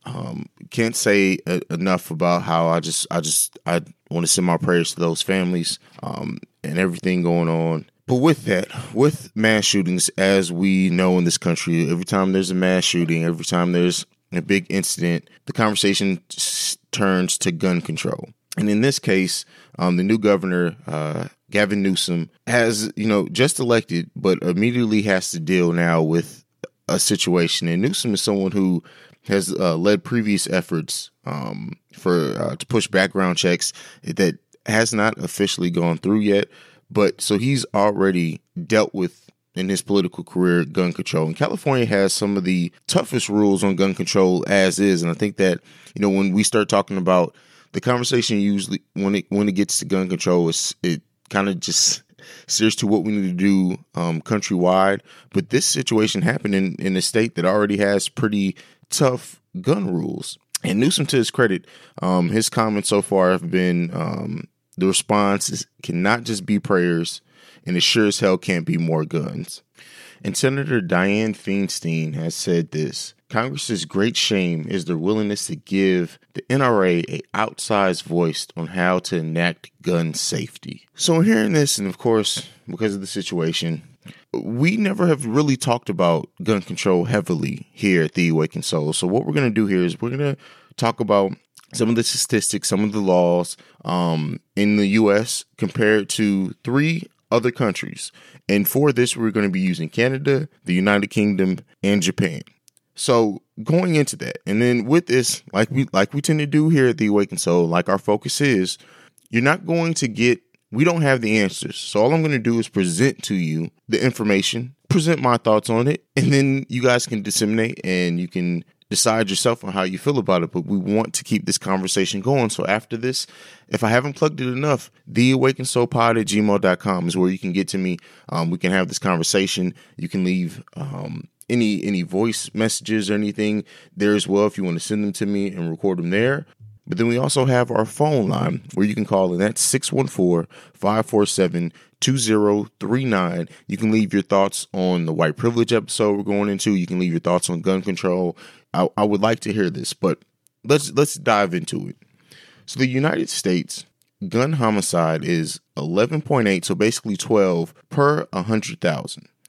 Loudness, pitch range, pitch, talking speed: -20 LUFS, 90-120 Hz, 100 Hz, 185 wpm